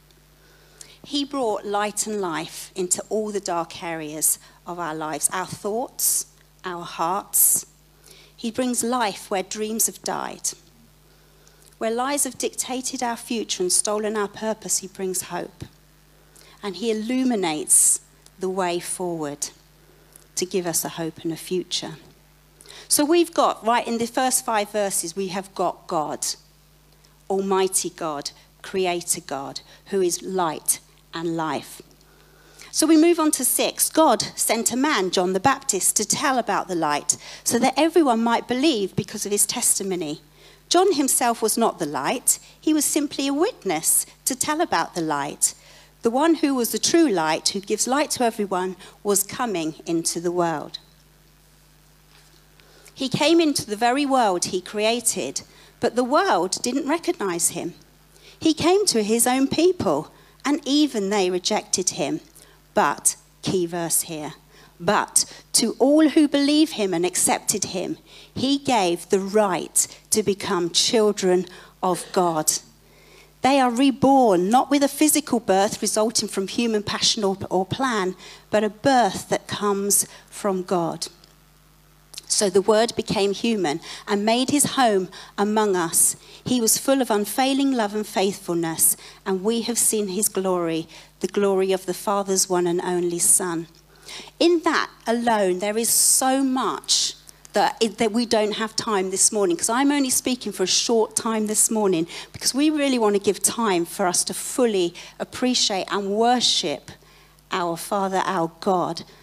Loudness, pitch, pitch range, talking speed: -21 LUFS, 205 Hz, 180-245 Hz, 155 wpm